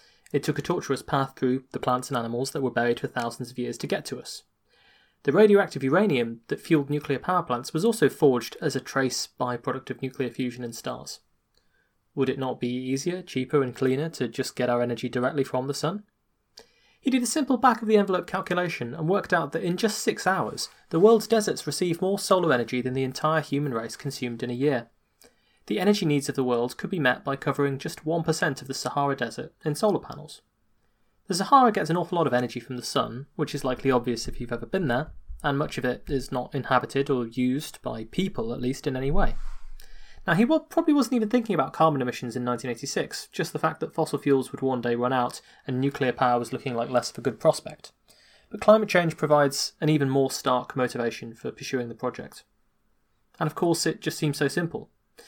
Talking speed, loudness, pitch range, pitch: 220 wpm, -26 LUFS, 125-165 Hz, 135 Hz